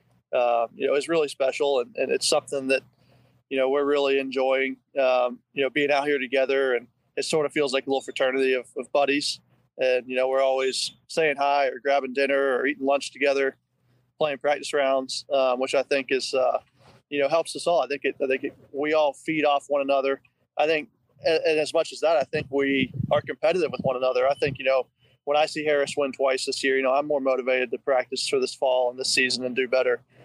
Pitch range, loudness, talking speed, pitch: 130-145 Hz, -24 LUFS, 235 wpm, 135 Hz